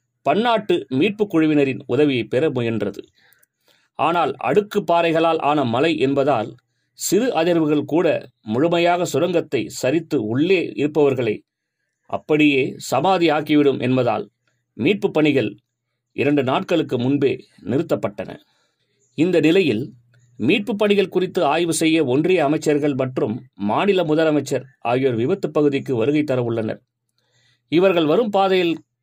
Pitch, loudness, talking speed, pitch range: 150 Hz, -19 LUFS, 105 wpm, 130-170 Hz